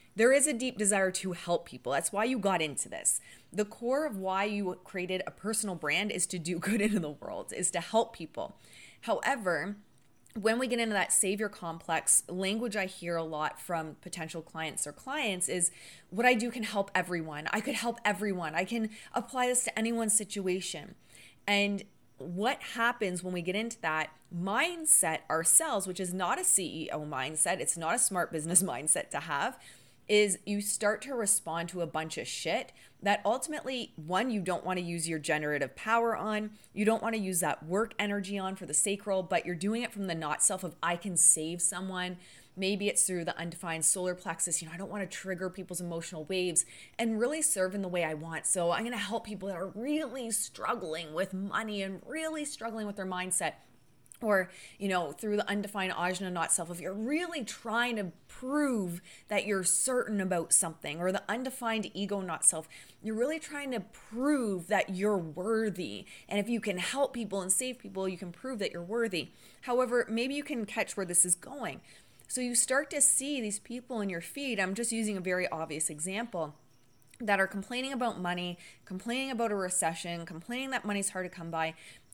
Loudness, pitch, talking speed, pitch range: -31 LUFS, 195 Hz, 200 wpm, 175-225 Hz